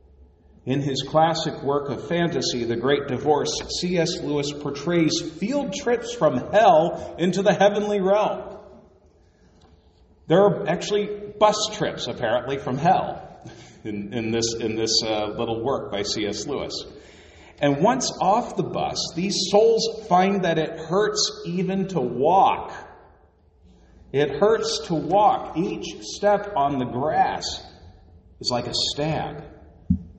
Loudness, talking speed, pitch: -23 LUFS, 125 wpm, 150 Hz